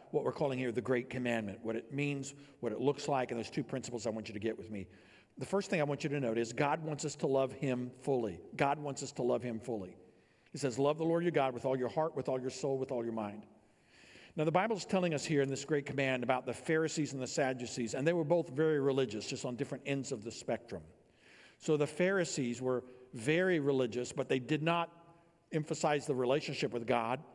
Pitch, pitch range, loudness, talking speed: 135 Hz, 125-150 Hz, -35 LUFS, 245 wpm